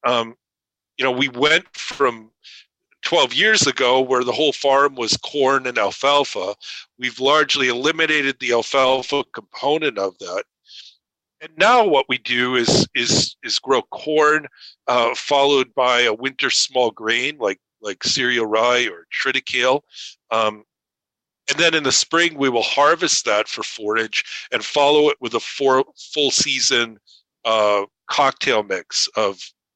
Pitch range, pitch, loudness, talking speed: 115-140 Hz, 130 Hz, -18 LUFS, 145 wpm